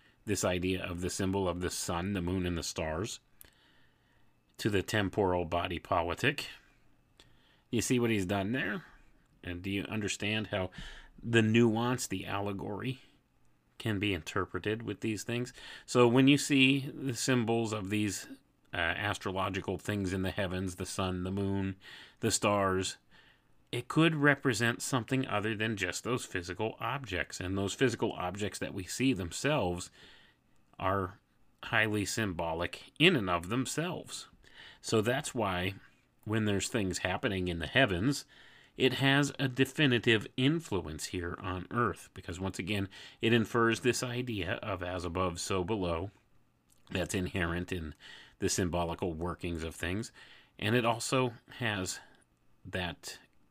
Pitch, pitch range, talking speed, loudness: 100 Hz, 90-120 Hz, 140 wpm, -32 LUFS